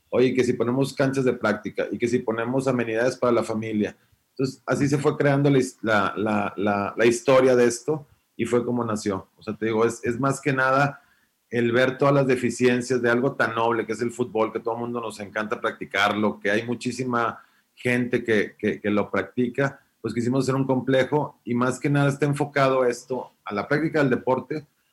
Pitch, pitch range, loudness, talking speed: 125 Hz, 115-135 Hz, -24 LUFS, 205 wpm